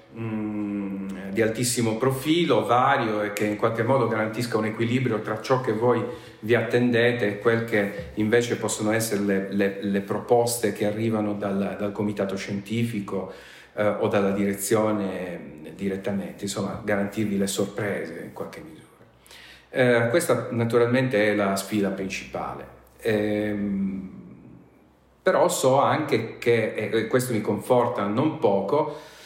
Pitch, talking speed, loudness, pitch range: 105 Hz, 135 wpm, -24 LUFS, 100-115 Hz